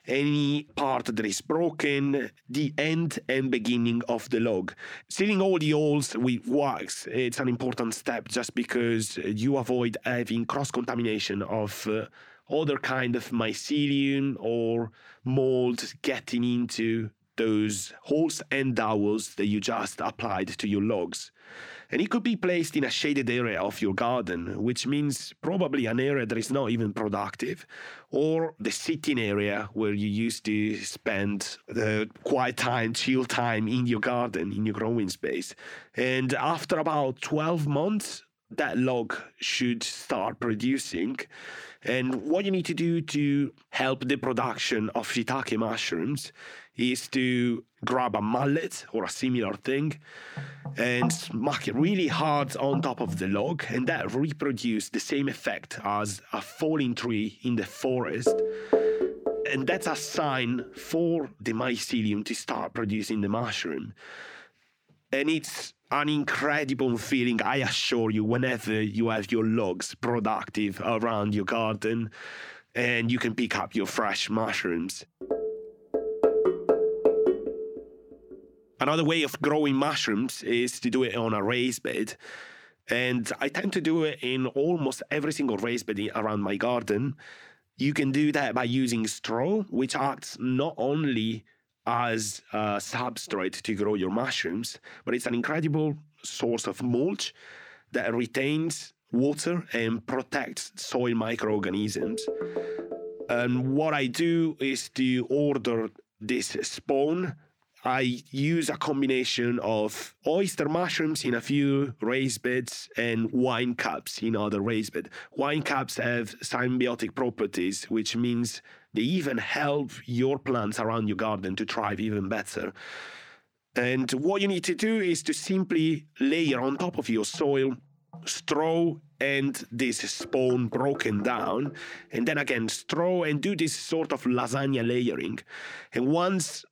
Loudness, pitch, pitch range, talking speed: -28 LUFS, 125 Hz, 115-150 Hz, 145 wpm